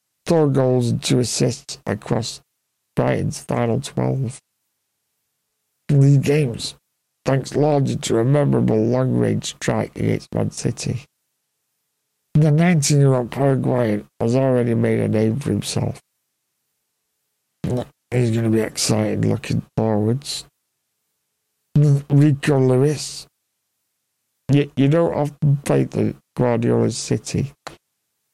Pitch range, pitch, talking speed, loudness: 115-145 Hz, 135 Hz, 110 wpm, -20 LUFS